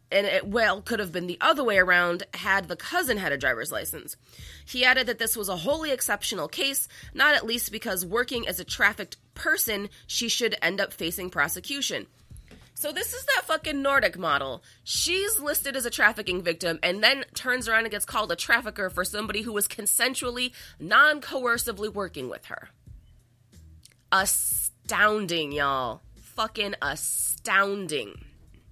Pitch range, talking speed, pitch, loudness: 180-250 Hz, 160 wpm, 210 Hz, -25 LUFS